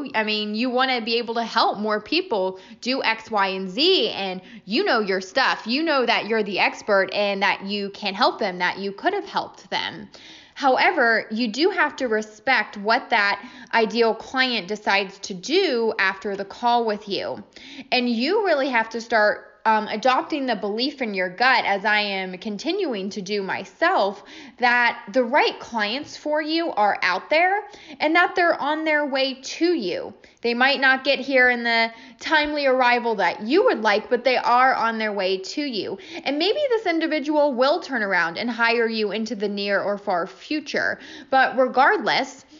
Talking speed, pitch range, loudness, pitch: 185 wpm, 210-290 Hz, -21 LUFS, 240 Hz